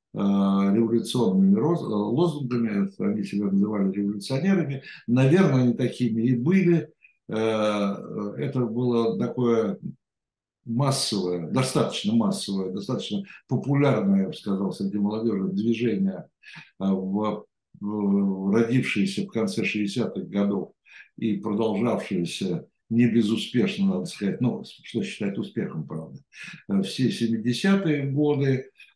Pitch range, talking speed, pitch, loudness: 100-145 Hz, 95 wpm, 115 Hz, -25 LUFS